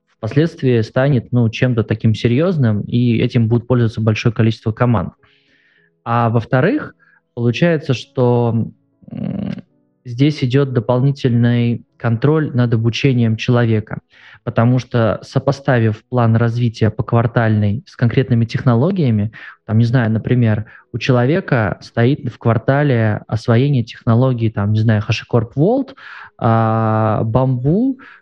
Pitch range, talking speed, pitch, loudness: 115-130 Hz, 110 wpm, 120 Hz, -16 LUFS